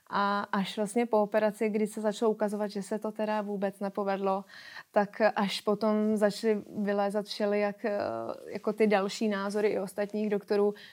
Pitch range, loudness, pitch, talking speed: 200-215 Hz, -30 LUFS, 210 Hz, 155 wpm